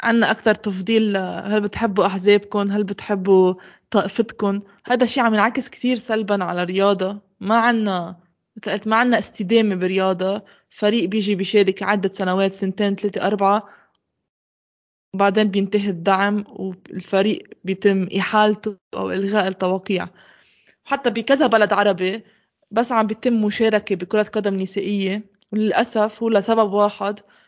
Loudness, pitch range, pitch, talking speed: -20 LUFS, 195-220 Hz, 205 Hz, 120 wpm